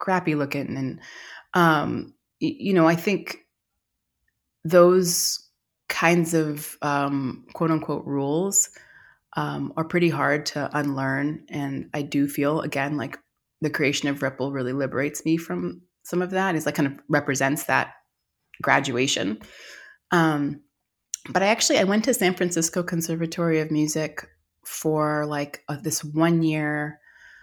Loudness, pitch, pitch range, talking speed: -24 LUFS, 150 Hz, 140-165 Hz, 135 wpm